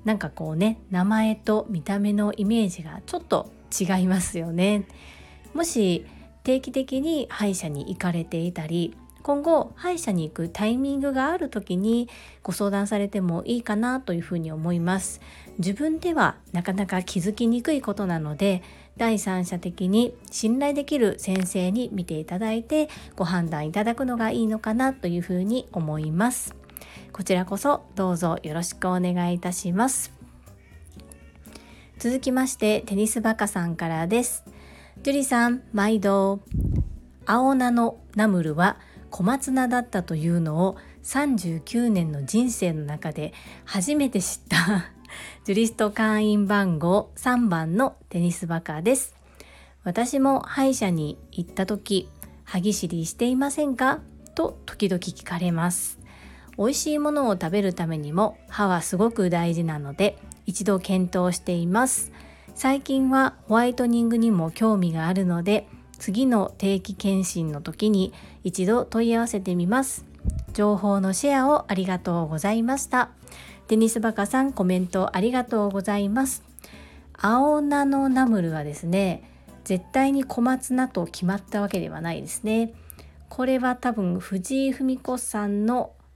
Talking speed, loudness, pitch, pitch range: 295 characters per minute, -24 LUFS, 200 Hz, 175-240 Hz